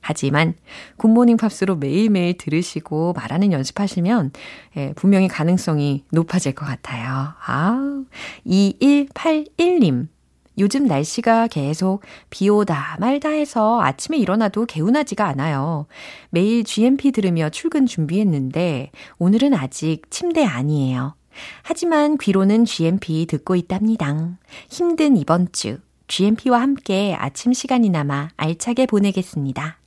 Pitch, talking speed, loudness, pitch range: 190 Hz, 280 characters per minute, -19 LUFS, 155-240 Hz